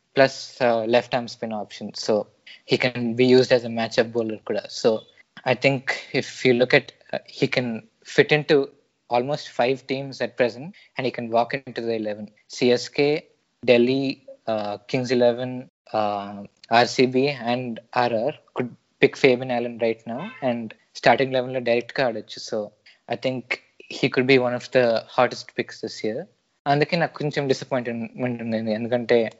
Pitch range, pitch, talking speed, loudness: 115-130 Hz, 125 Hz, 160 wpm, -23 LUFS